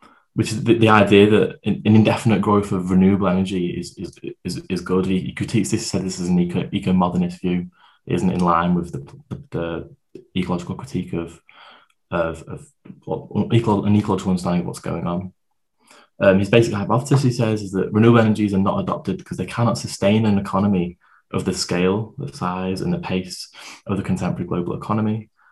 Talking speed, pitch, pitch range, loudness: 185 wpm, 95 Hz, 90-110 Hz, -20 LUFS